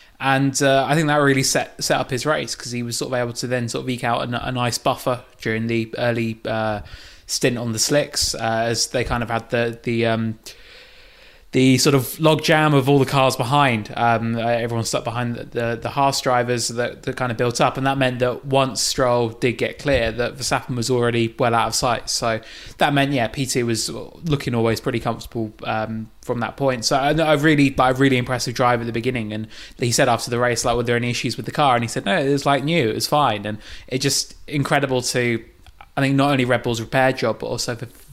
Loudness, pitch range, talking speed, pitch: -20 LUFS, 115-135 Hz, 240 wpm, 125 Hz